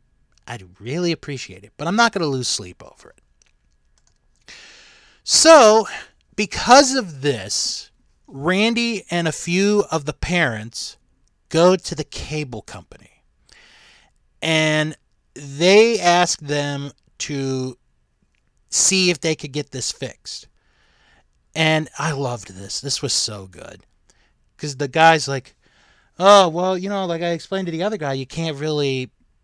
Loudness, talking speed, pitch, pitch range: -18 LUFS, 135 wpm, 155 Hz, 130-180 Hz